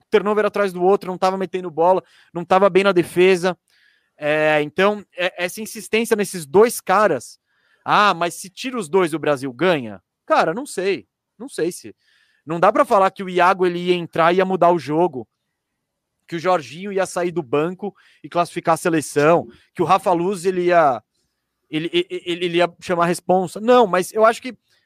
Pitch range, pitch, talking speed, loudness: 170-200 Hz, 180 Hz, 195 wpm, -19 LUFS